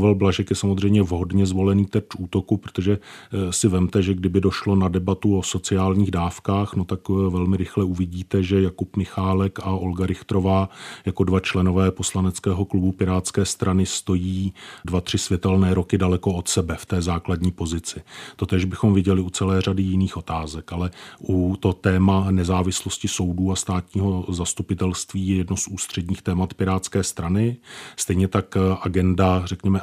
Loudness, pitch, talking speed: -22 LUFS, 95 Hz, 155 wpm